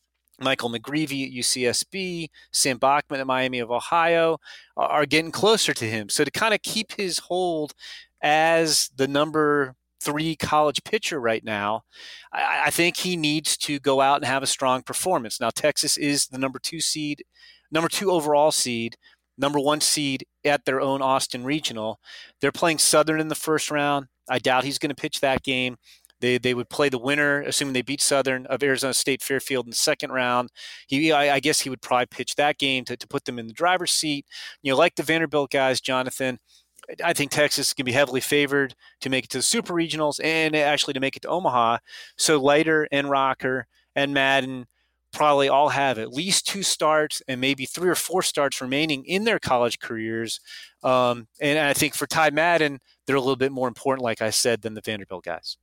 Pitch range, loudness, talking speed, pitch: 130-155 Hz, -23 LUFS, 200 wpm, 140 Hz